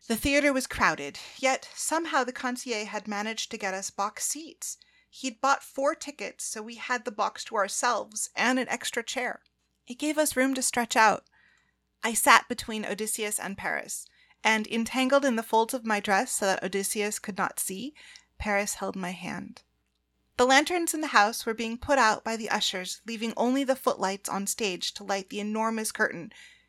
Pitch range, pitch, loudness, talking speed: 205-265 Hz, 225 Hz, -27 LUFS, 190 wpm